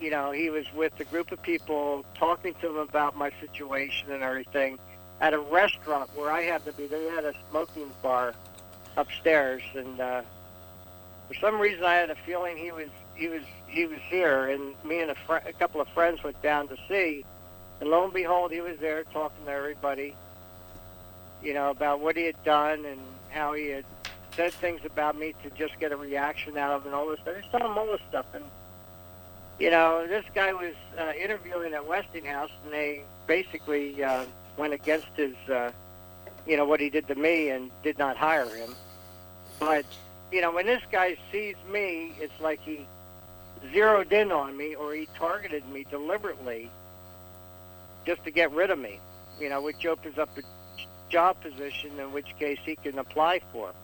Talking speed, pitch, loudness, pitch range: 190 wpm, 145 Hz, -29 LUFS, 125-165 Hz